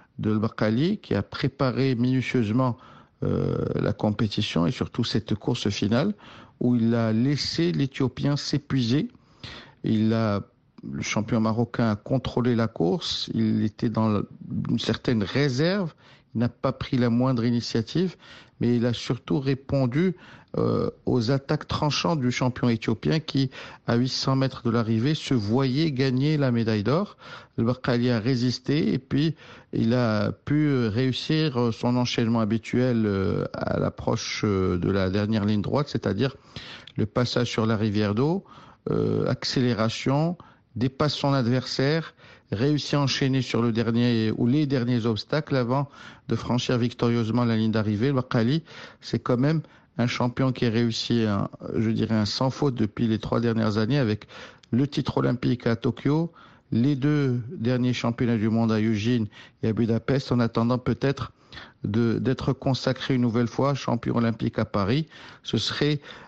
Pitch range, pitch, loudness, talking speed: 115-135 Hz, 125 Hz, -25 LUFS, 150 wpm